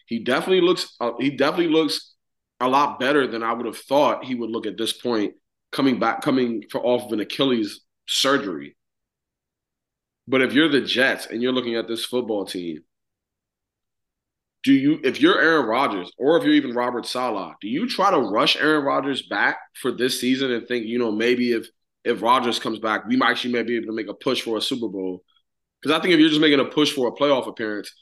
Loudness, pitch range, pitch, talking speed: -21 LUFS, 110-150 Hz, 125 Hz, 215 wpm